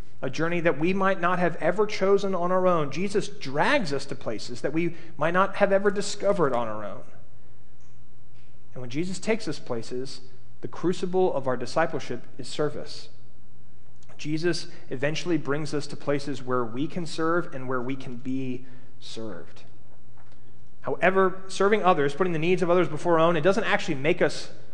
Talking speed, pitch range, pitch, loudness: 175 wpm, 130-185 Hz, 160 Hz, -26 LUFS